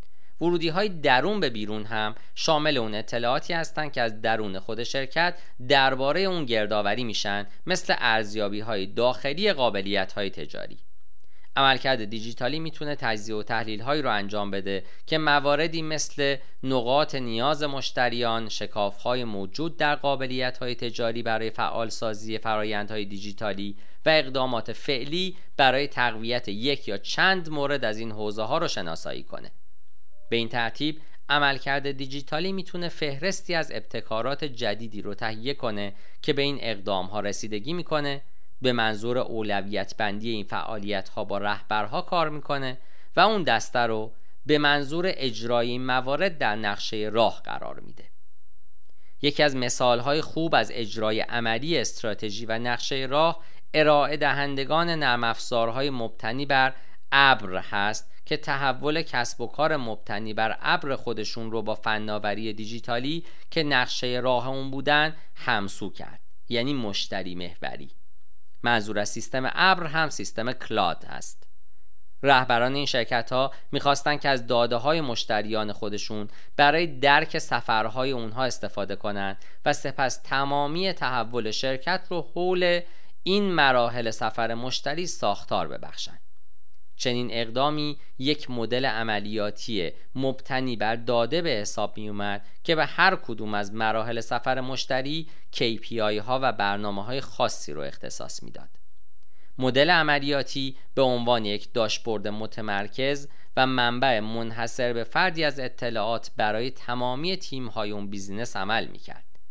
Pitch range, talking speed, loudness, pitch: 110-145 Hz, 135 wpm, -26 LUFS, 120 Hz